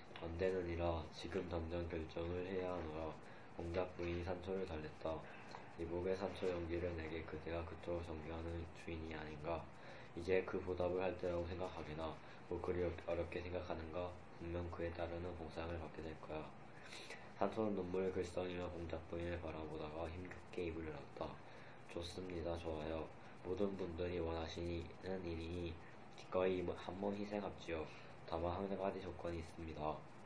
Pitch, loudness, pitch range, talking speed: 85 Hz, -45 LUFS, 80-90 Hz, 325 characters per minute